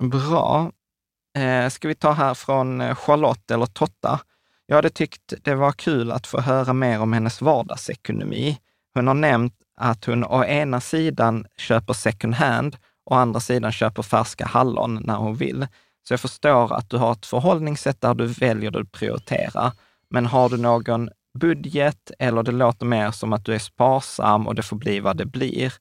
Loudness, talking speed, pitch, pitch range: -22 LUFS, 180 wpm, 125 Hz, 115-135 Hz